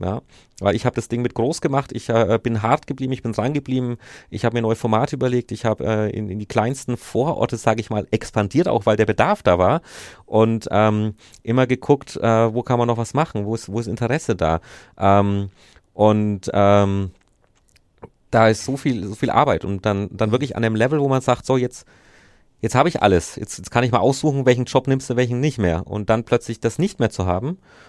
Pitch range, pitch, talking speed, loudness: 105-130 Hz, 115 Hz, 230 wpm, -20 LUFS